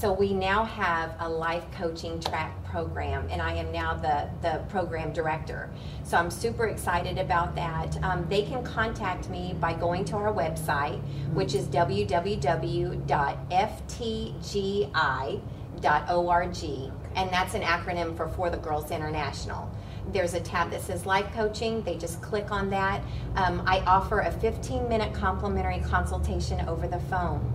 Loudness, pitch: -29 LUFS, 145 Hz